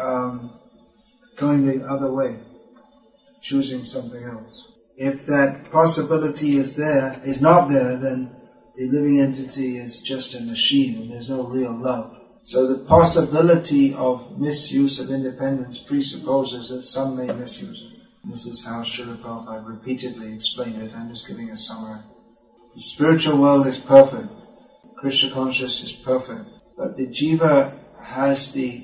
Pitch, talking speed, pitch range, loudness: 135 Hz, 145 wpm, 125-160 Hz, -20 LUFS